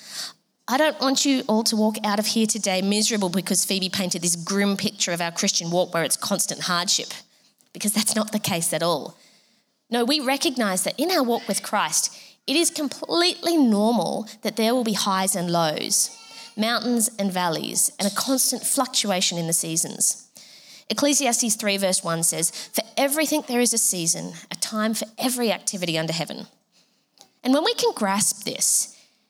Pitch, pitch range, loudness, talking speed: 215 Hz, 190-240 Hz, -22 LUFS, 180 wpm